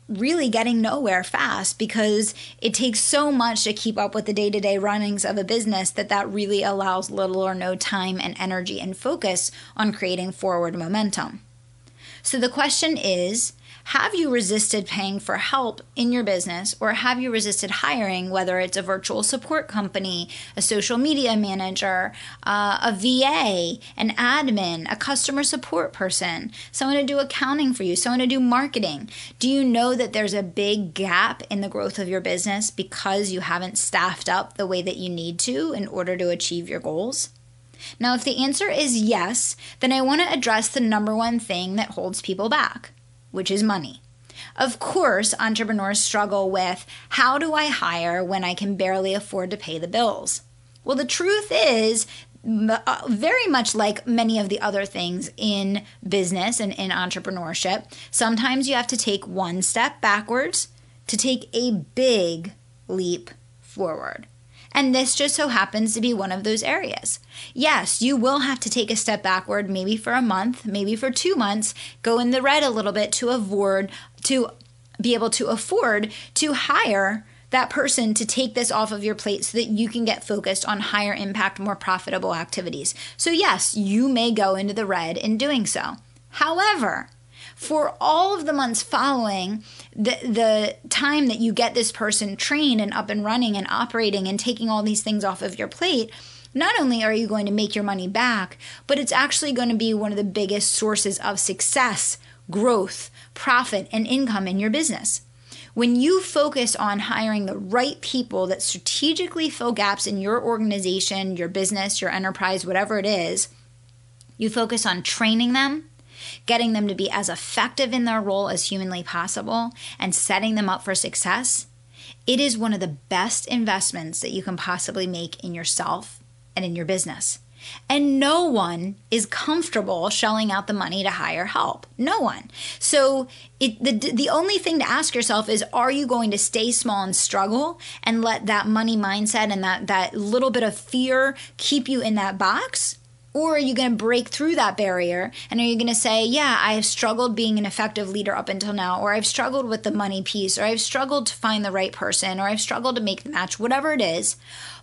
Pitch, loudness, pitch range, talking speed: 210 Hz, -22 LUFS, 190-245 Hz, 185 wpm